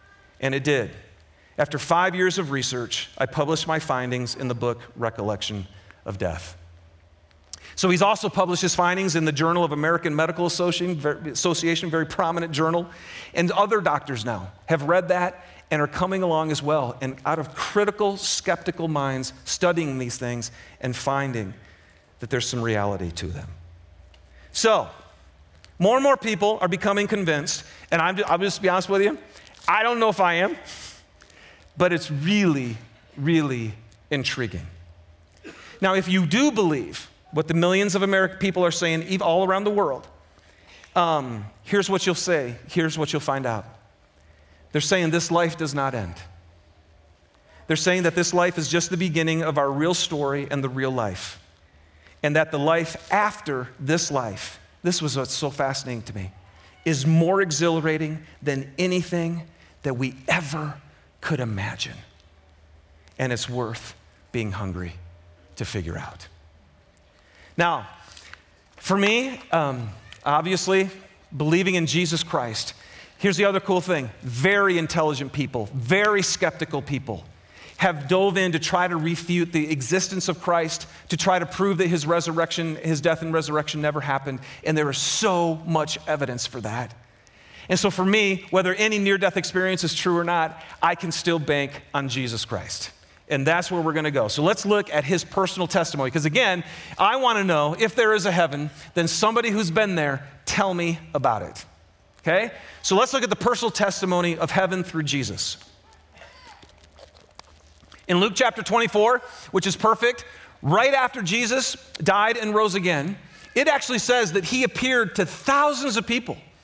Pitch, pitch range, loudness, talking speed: 155 Hz, 115-185 Hz, -23 LUFS, 165 wpm